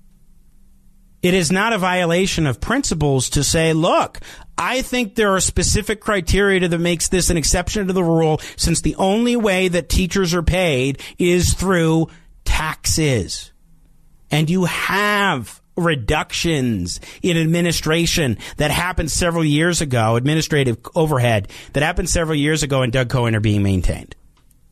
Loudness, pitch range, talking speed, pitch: -18 LUFS, 130-185 Hz, 145 wpm, 165 Hz